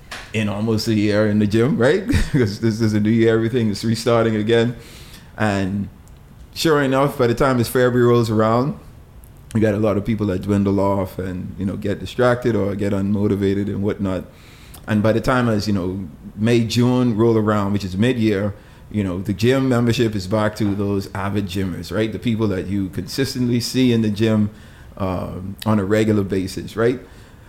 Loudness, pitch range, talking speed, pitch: -19 LUFS, 100-115 Hz, 190 wpm, 110 Hz